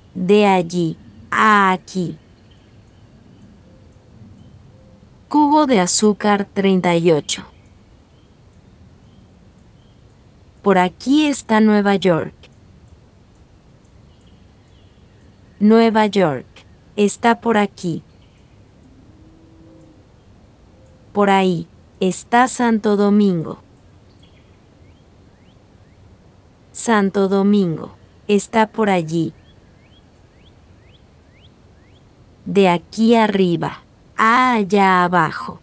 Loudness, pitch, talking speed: -16 LUFS, 135 Hz, 60 wpm